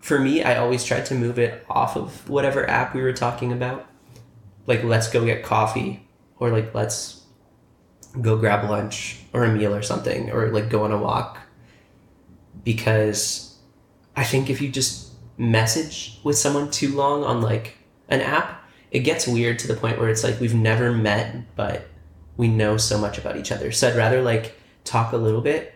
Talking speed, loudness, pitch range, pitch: 190 wpm, -22 LUFS, 110-125 Hz, 115 Hz